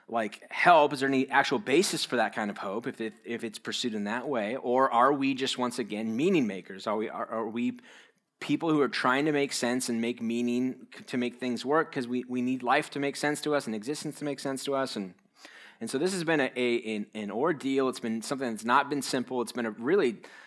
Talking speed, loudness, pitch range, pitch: 250 wpm, -29 LUFS, 120-140 Hz, 125 Hz